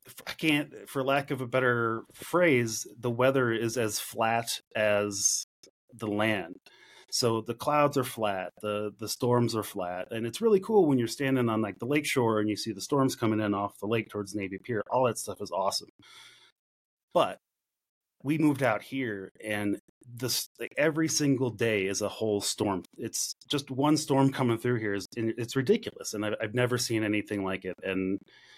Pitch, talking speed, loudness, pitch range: 115 Hz, 185 wpm, -29 LUFS, 105-135 Hz